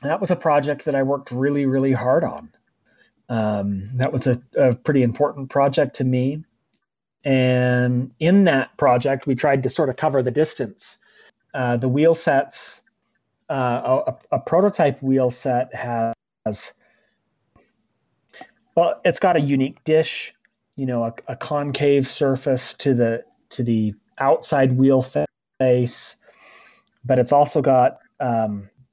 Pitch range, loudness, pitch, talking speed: 125-145 Hz, -20 LUFS, 130 Hz, 140 wpm